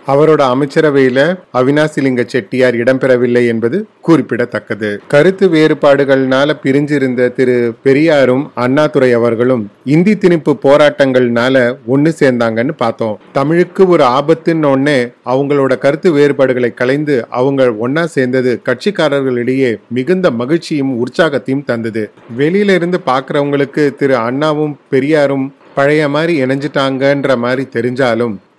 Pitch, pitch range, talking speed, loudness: 135 Hz, 125-150 Hz, 95 wpm, -12 LUFS